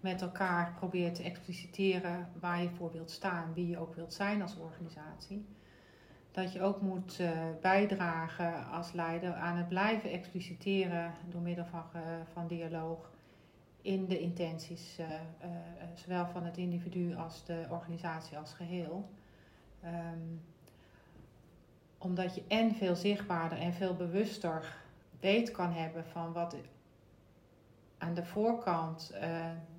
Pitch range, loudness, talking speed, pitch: 165-180 Hz, -37 LUFS, 135 wpm, 175 Hz